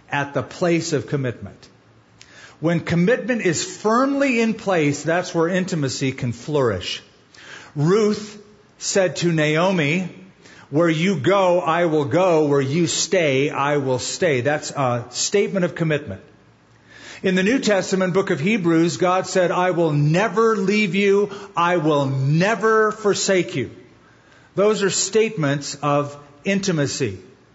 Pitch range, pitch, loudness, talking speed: 145-195 Hz, 175 Hz, -20 LUFS, 135 wpm